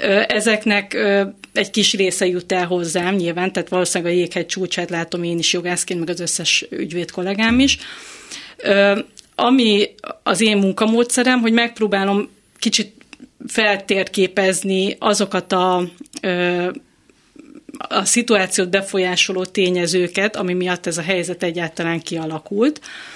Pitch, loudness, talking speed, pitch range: 195 Hz, -18 LUFS, 115 wpm, 180-220 Hz